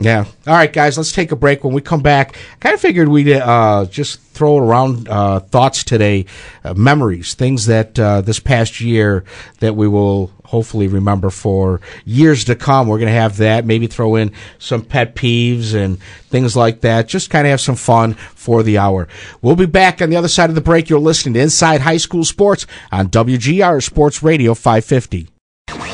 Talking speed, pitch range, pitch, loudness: 200 wpm, 105-145 Hz, 115 Hz, -13 LUFS